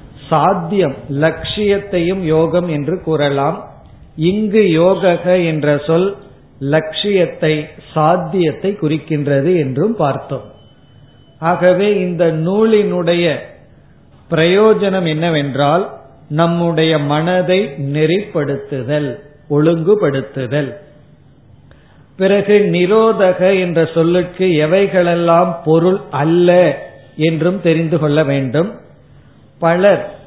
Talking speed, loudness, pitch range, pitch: 70 wpm, -14 LUFS, 150-185 Hz, 165 Hz